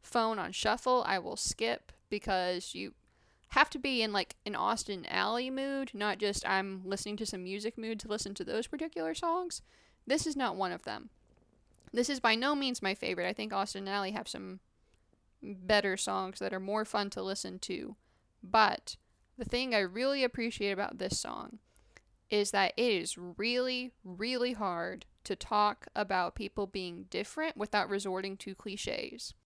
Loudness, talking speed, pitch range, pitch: -34 LUFS, 175 wpm, 195-245 Hz, 210 Hz